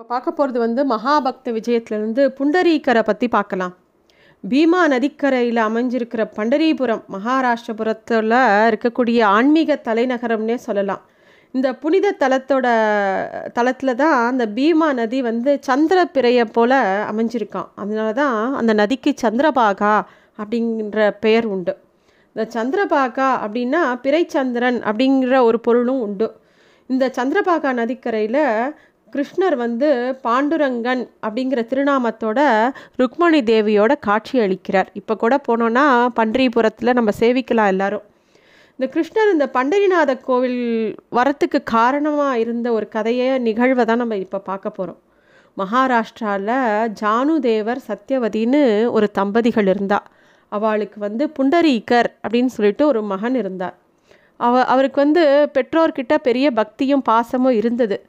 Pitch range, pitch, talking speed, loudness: 220-275 Hz, 240 Hz, 105 wpm, -18 LUFS